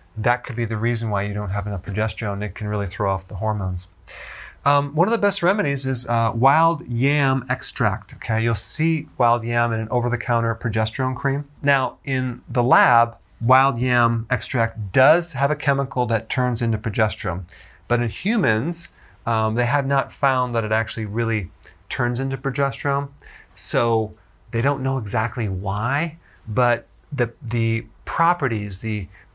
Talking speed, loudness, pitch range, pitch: 165 wpm, -21 LUFS, 110-135 Hz, 120 Hz